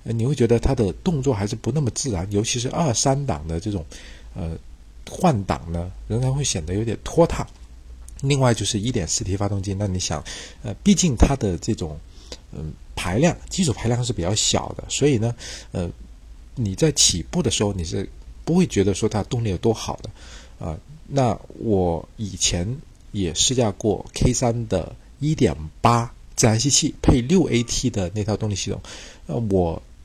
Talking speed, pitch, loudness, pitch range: 260 characters per minute, 105 Hz, -22 LUFS, 85-120 Hz